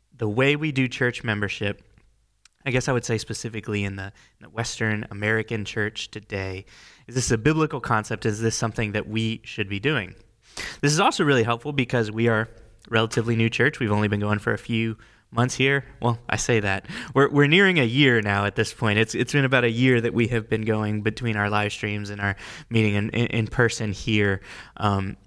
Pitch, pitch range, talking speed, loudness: 115 Hz, 105-120 Hz, 215 wpm, -23 LUFS